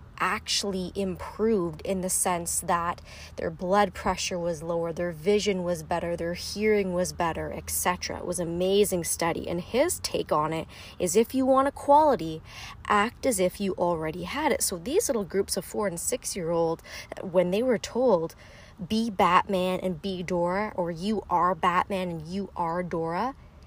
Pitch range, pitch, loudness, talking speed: 170-205 Hz, 185 Hz, -27 LUFS, 175 wpm